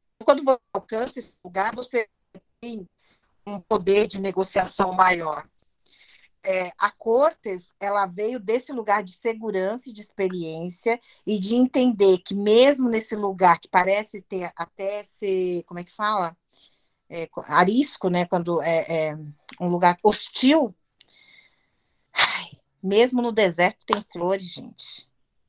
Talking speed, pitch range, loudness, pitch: 125 wpm, 180-225 Hz, -23 LUFS, 200 Hz